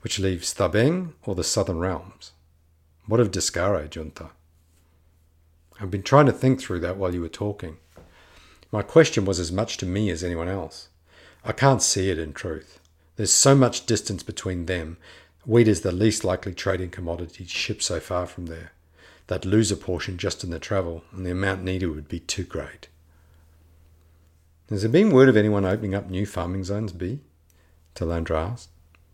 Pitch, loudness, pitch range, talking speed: 90 Hz, -23 LUFS, 80-105 Hz, 175 wpm